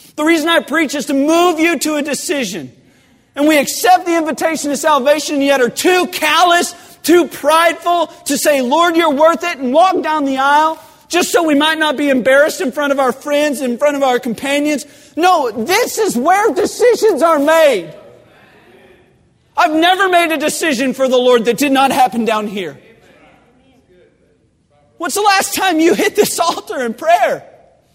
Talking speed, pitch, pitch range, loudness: 180 wpm, 310 Hz, 280-345 Hz, -13 LUFS